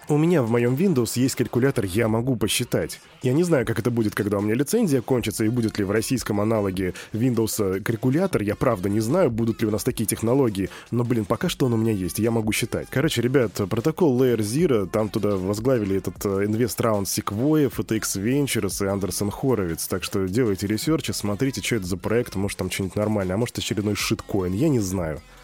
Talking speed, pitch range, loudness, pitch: 205 wpm, 105-125 Hz, -23 LUFS, 115 Hz